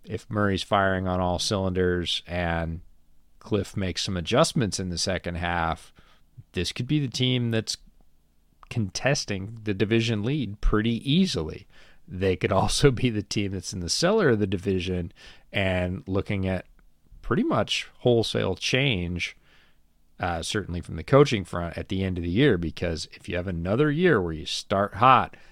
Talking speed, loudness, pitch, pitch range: 160 wpm, -25 LUFS, 95 Hz, 85-110 Hz